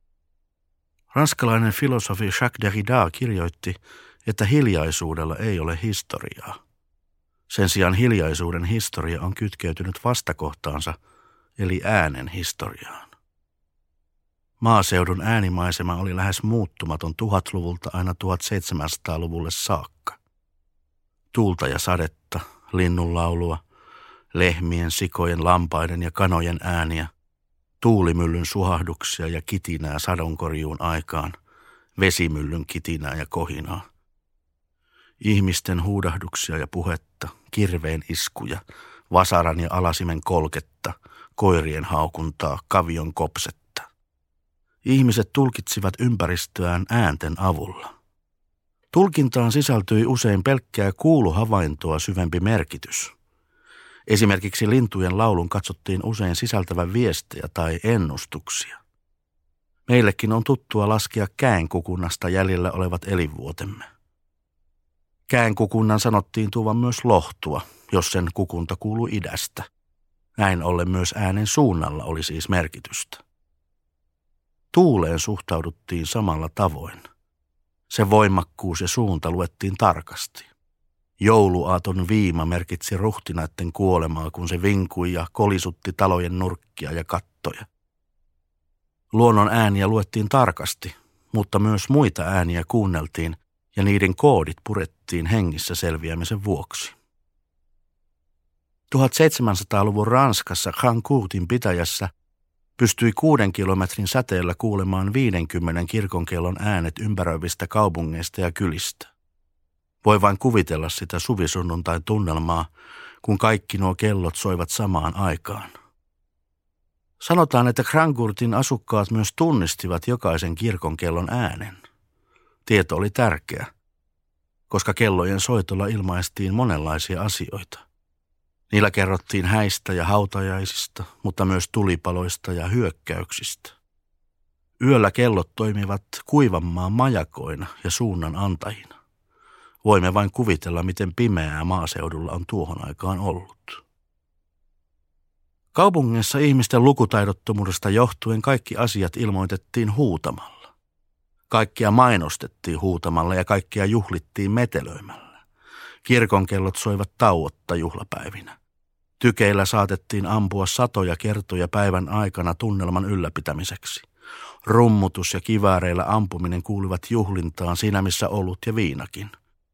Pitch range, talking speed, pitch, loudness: 80-105 Hz, 95 wpm, 90 Hz, -22 LUFS